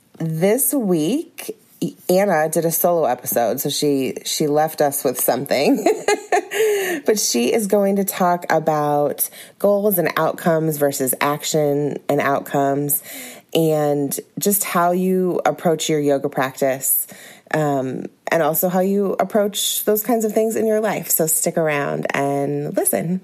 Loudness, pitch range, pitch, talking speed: -19 LUFS, 145-205 Hz, 165 Hz, 140 wpm